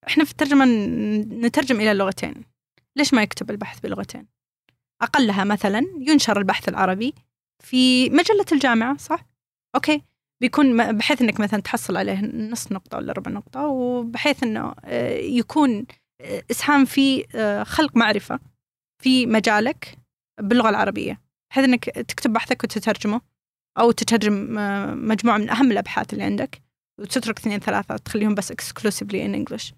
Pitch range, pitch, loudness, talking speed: 210-270 Hz, 235 Hz, -21 LUFS, 125 wpm